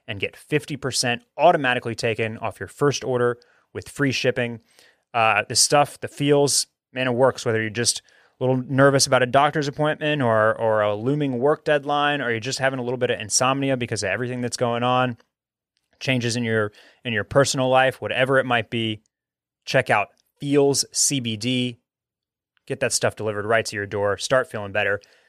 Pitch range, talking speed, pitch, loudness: 115-135 Hz, 185 wpm, 125 Hz, -21 LUFS